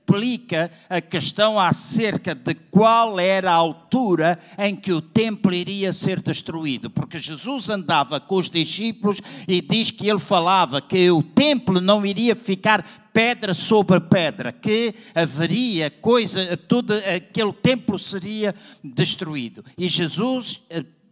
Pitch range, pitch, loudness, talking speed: 170-215 Hz, 190 Hz, -20 LUFS, 130 wpm